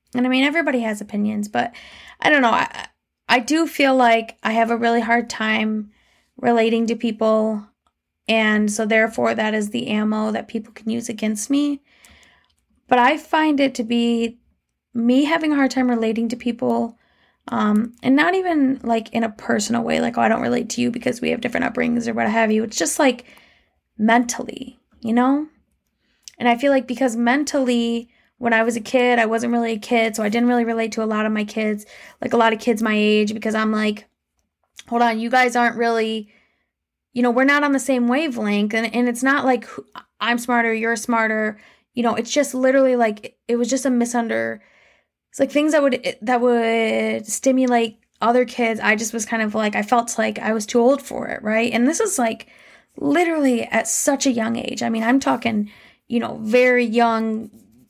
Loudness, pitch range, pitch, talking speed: -19 LUFS, 225-250 Hz, 235 Hz, 205 wpm